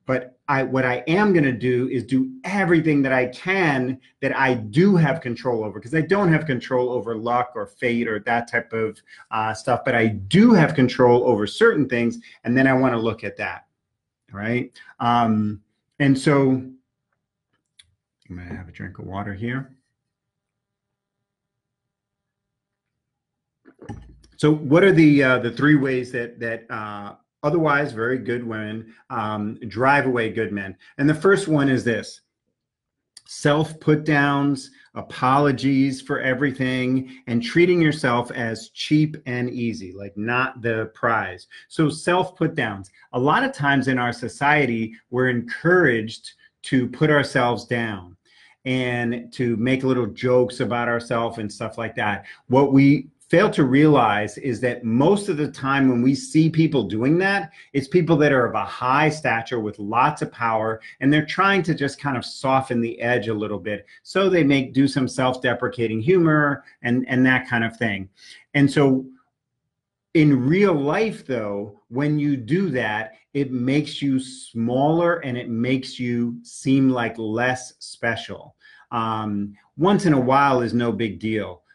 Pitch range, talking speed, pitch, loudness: 115-145 Hz, 165 wpm, 130 Hz, -21 LUFS